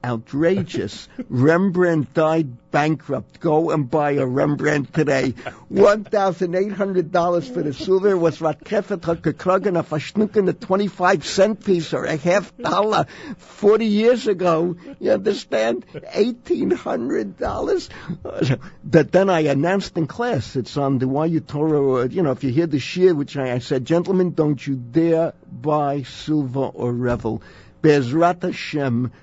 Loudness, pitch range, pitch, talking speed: -20 LUFS, 140-185 Hz, 160 Hz, 125 wpm